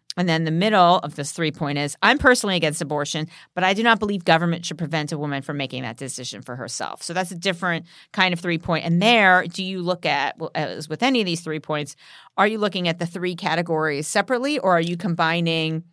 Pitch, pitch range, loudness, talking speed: 170 Hz, 155-185 Hz, -21 LUFS, 235 wpm